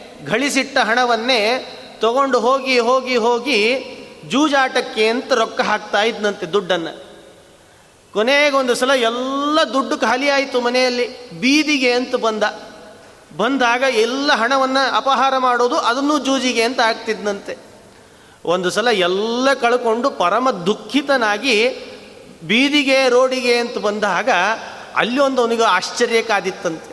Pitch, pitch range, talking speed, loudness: 245 Hz, 225-270 Hz, 105 wpm, -17 LUFS